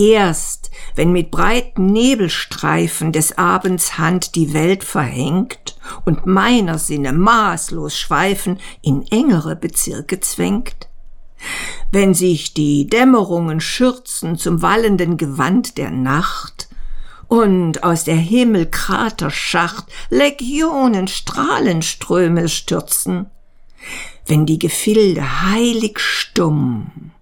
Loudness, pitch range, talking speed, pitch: -16 LUFS, 160-215 Hz, 95 wpm, 180 Hz